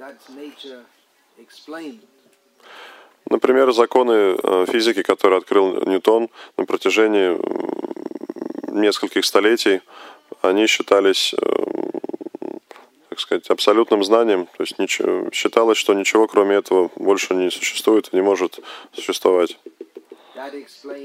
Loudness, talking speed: -18 LUFS, 85 wpm